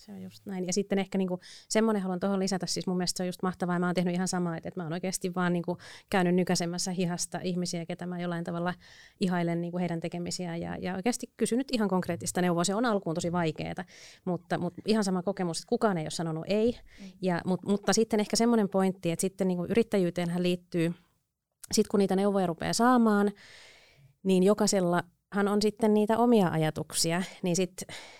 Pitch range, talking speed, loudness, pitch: 175-200 Hz, 200 wpm, -29 LUFS, 185 Hz